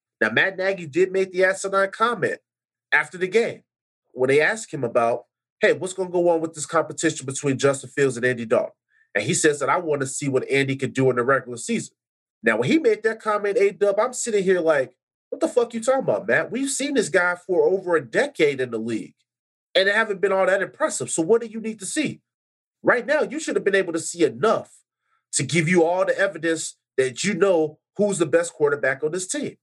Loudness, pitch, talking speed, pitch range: -22 LUFS, 190 Hz, 240 wpm, 150-230 Hz